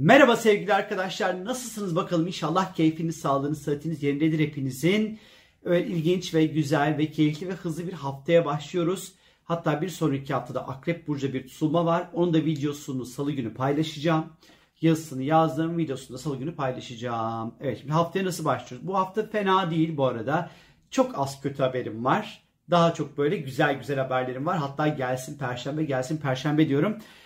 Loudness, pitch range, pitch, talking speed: -26 LUFS, 140-175 Hz, 155 Hz, 160 wpm